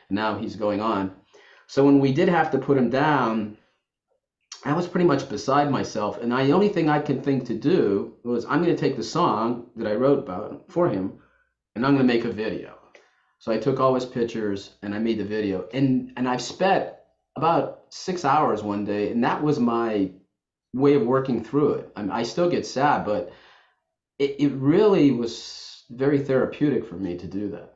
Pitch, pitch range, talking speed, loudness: 125 Hz, 110-140 Hz, 210 wpm, -23 LUFS